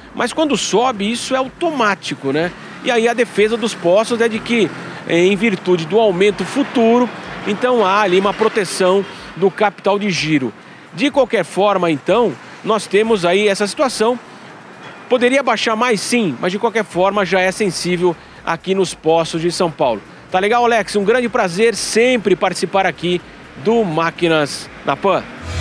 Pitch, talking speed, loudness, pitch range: 205 Hz, 160 wpm, -16 LUFS, 180-230 Hz